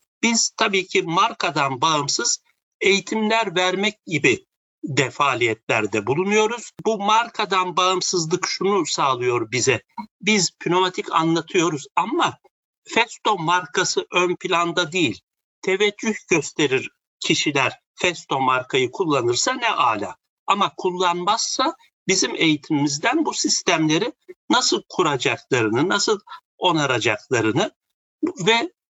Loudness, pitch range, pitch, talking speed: -20 LUFS, 180-240 Hz, 205 Hz, 90 wpm